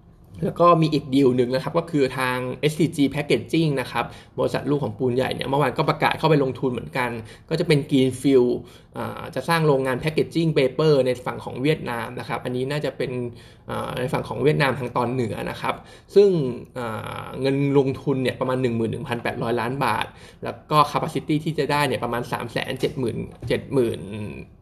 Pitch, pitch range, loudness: 130 Hz, 125-150 Hz, -23 LUFS